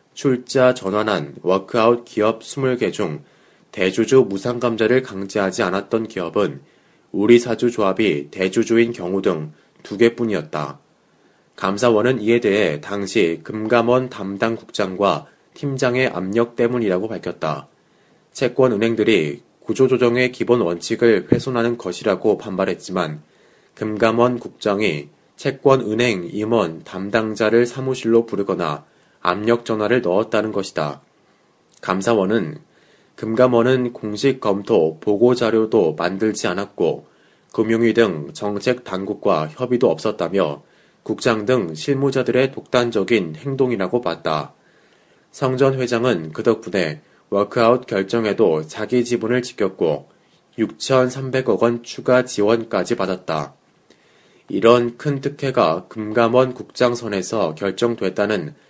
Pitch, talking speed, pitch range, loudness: 115 Hz, 265 characters per minute, 100-125 Hz, -19 LUFS